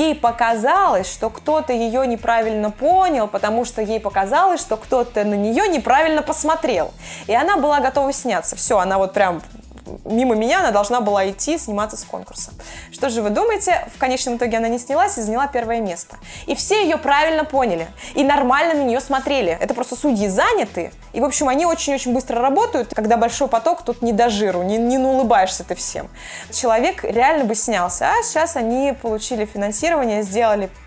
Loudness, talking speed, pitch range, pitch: -18 LUFS, 180 wpm, 220-290 Hz, 245 Hz